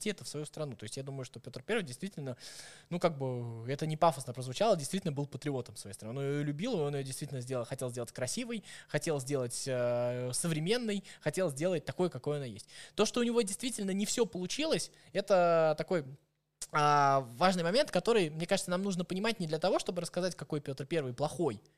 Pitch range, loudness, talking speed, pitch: 135-185 Hz, -34 LUFS, 200 wpm, 155 Hz